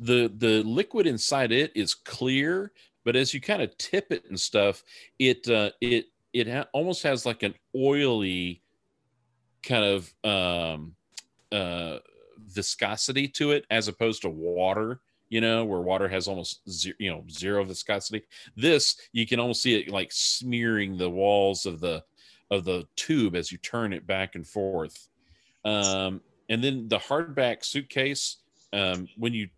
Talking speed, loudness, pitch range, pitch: 160 wpm, -27 LUFS, 95-125 Hz, 110 Hz